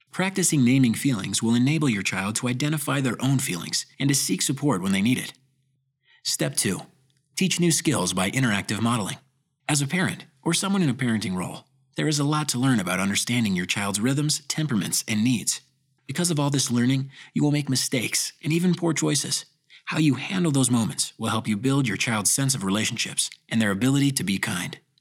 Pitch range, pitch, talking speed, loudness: 120-150 Hz, 135 Hz, 200 wpm, -24 LUFS